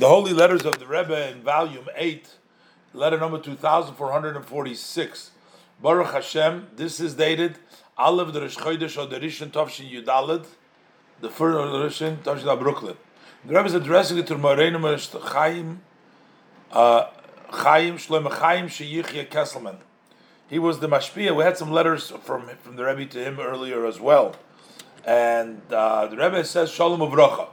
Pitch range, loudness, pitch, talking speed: 140-165 Hz, -22 LUFS, 155 Hz, 155 wpm